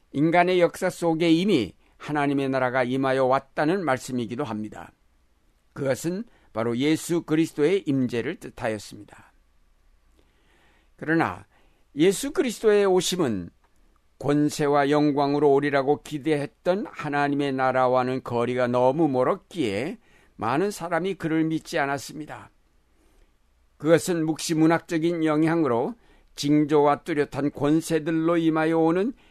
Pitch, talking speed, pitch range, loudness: 145 Hz, 285 characters per minute, 125-165 Hz, -24 LUFS